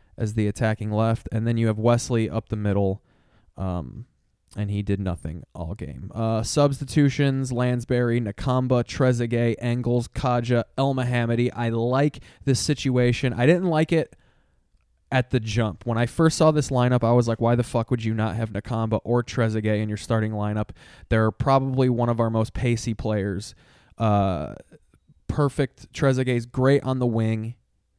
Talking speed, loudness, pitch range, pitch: 165 wpm, -23 LUFS, 110-130 Hz, 120 Hz